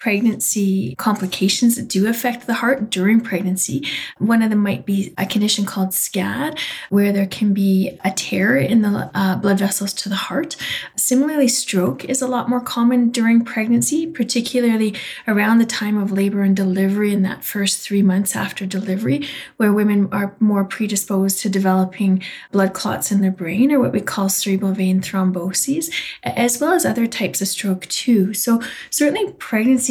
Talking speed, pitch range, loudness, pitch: 175 wpm, 195-235 Hz, -18 LUFS, 205 Hz